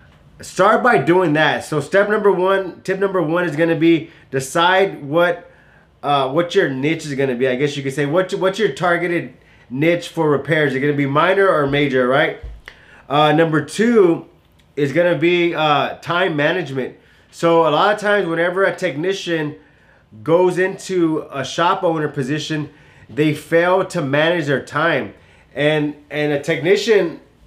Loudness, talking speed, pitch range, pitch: -17 LUFS, 175 wpm, 145-180 Hz, 165 Hz